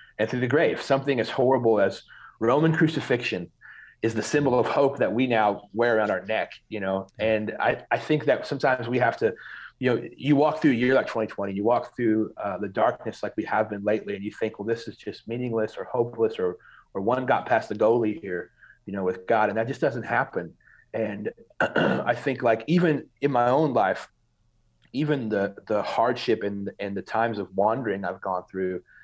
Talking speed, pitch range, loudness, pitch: 210 wpm, 105-135 Hz, -25 LUFS, 115 Hz